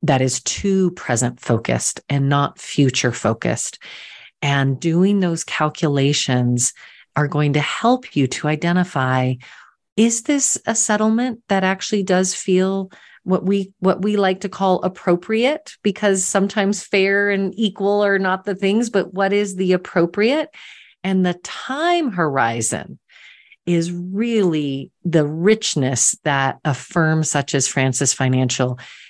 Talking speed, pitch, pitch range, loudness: 135 wpm, 180 Hz, 140-200 Hz, -19 LUFS